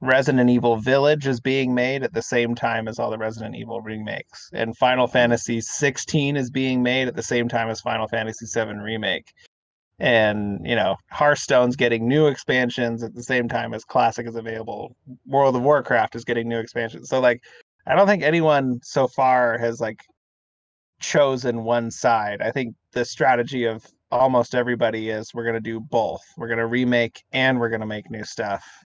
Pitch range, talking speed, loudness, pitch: 115-130 Hz, 190 wpm, -22 LUFS, 120 Hz